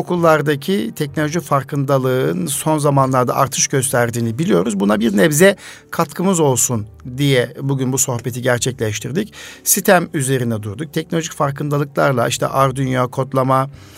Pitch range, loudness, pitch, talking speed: 130-160 Hz, -17 LUFS, 140 Hz, 110 wpm